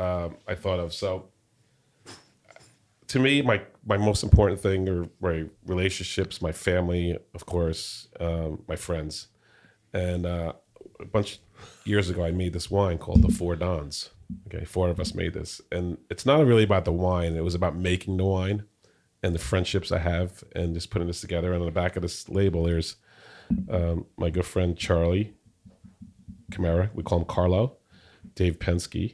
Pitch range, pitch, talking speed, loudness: 85-100 Hz, 90 Hz, 175 wpm, -27 LUFS